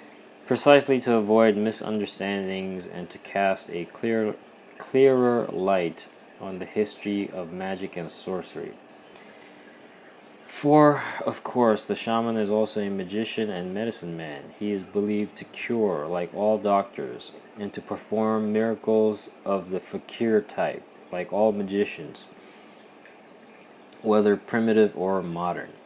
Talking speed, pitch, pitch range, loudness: 125 wpm, 105 Hz, 95-110 Hz, -25 LUFS